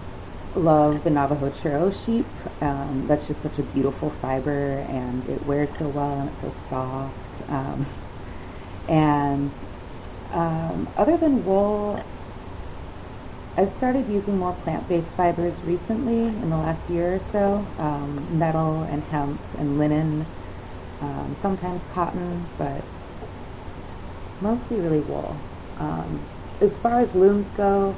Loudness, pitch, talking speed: -24 LUFS, 150 Hz, 130 wpm